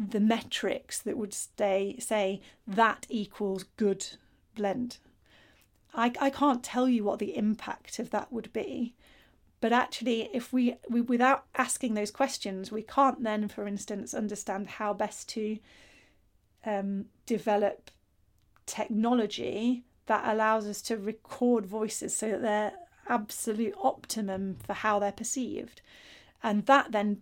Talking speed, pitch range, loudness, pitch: 135 wpm, 205-240 Hz, -30 LUFS, 220 Hz